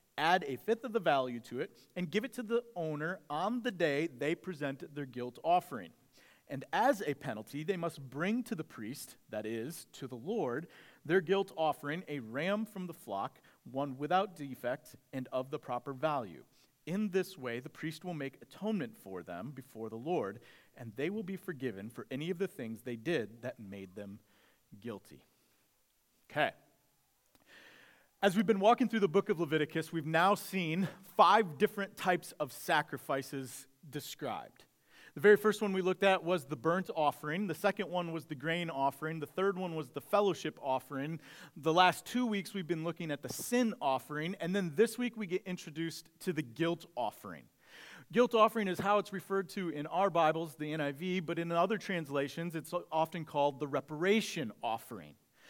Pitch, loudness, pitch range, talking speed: 165 Hz, -35 LUFS, 145-195 Hz, 185 wpm